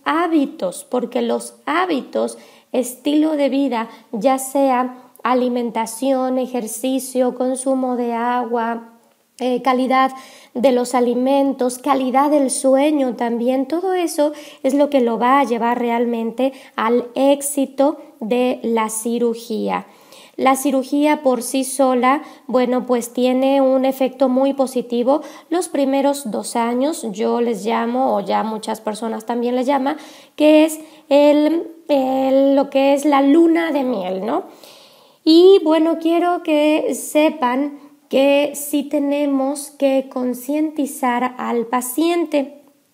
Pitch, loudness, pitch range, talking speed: 265 Hz, -18 LUFS, 245-285 Hz, 125 wpm